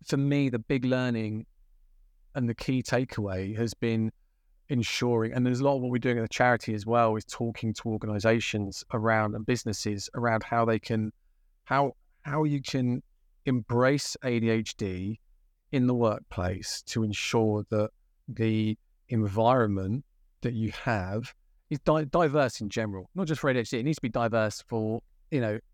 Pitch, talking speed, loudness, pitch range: 115 Hz, 165 wpm, -29 LUFS, 105-125 Hz